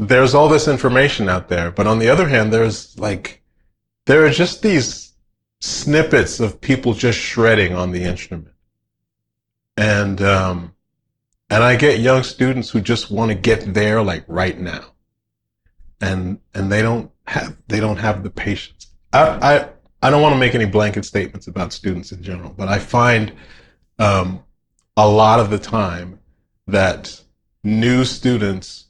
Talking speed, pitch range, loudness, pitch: 160 wpm, 95-115 Hz, -16 LUFS, 105 Hz